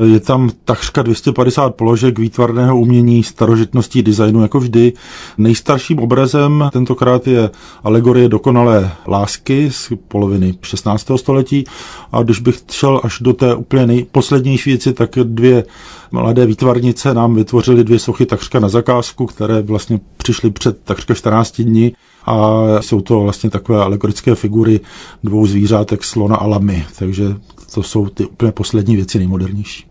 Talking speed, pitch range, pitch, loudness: 140 wpm, 105-125 Hz, 115 Hz, -13 LUFS